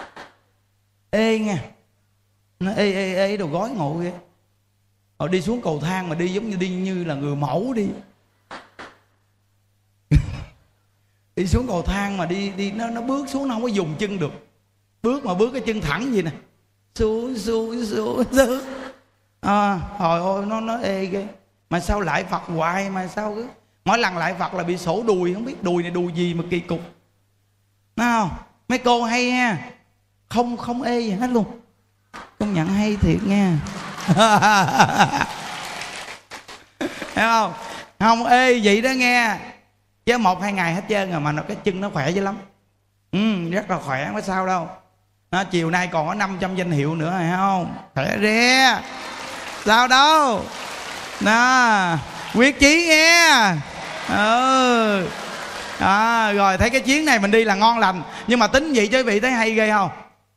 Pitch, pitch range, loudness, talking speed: 195 Hz, 160-225 Hz, -20 LUFS, 170 wpm